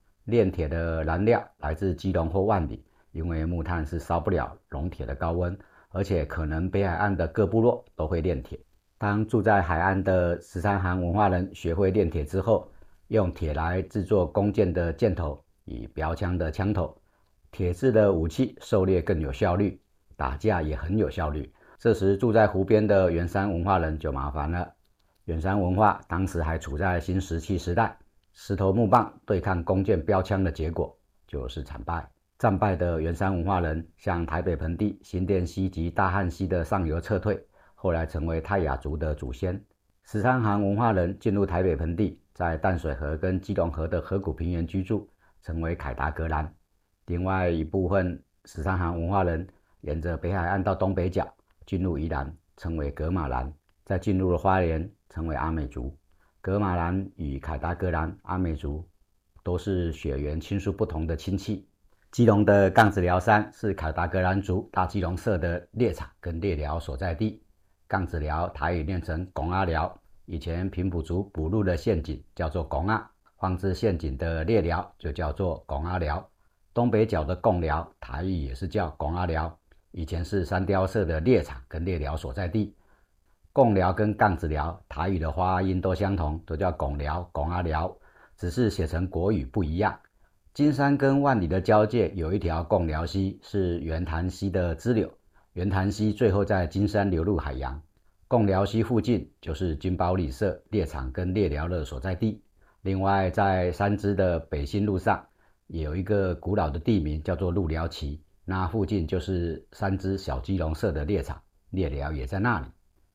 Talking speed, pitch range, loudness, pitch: 260 characters per minute, 80-100 Hz, -27 LUFS, 90 Hz